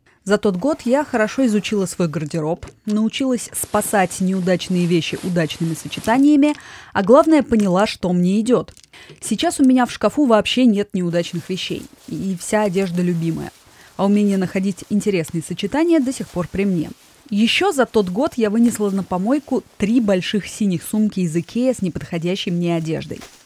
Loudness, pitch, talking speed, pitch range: -19 LUFS, 200 Hz, 155 wpm, 180-230 Hz